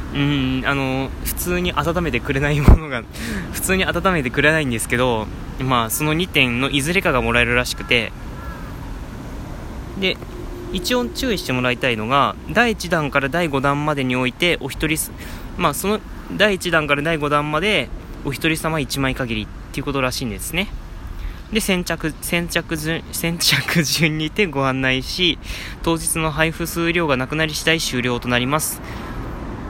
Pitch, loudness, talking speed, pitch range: 145 Hz, -19 LUFS, 305 characters per minute, 130-170 Hz